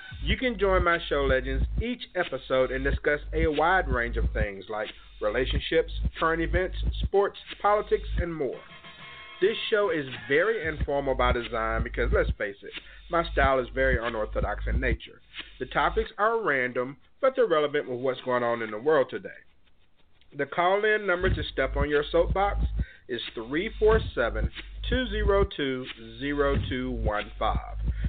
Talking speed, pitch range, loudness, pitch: 145 wpm, 130-200 Hz, -27 LUFS, 145 Hz